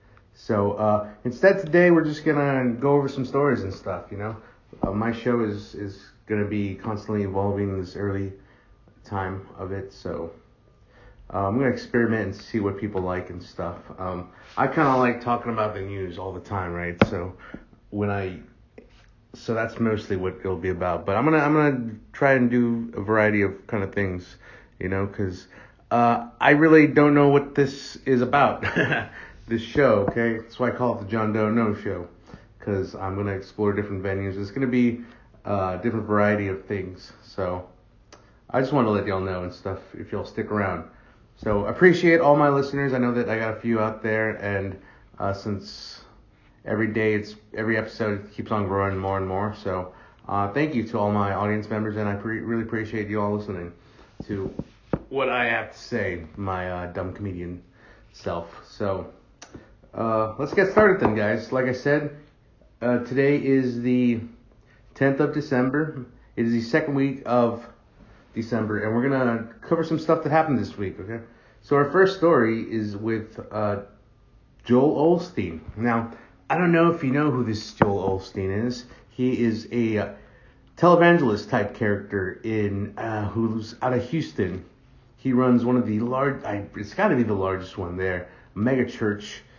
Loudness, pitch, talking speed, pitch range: -24 LUFS, 110 Hz, 185 wpm, 100-125 Hz